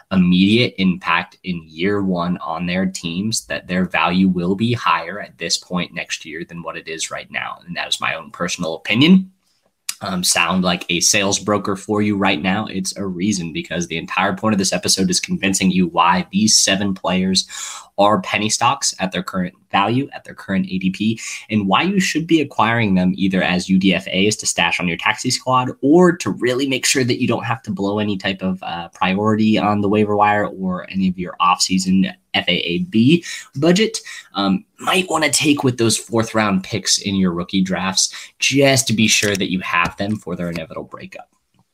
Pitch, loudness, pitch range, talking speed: 100 Hz, -17 LUFS, 95-125 Hz, 200 wpm